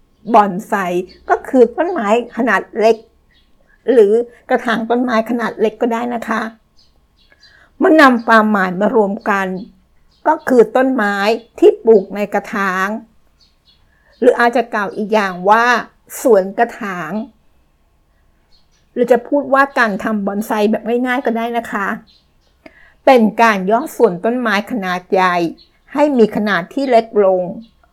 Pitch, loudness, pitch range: 220 Hz, -14 LUFS, 200-240 Hz